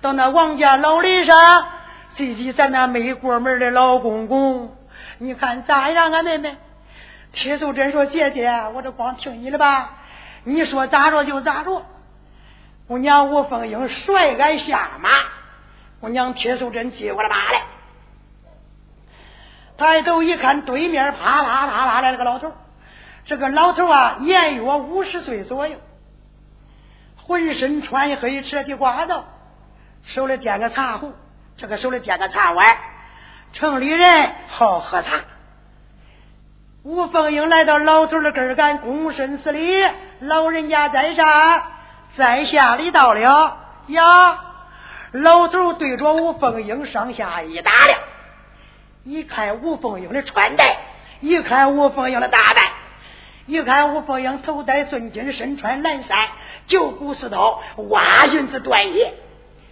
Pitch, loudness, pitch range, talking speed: 285 Hz, -16 LUFS, 255-320 Hz, 200 characters per minute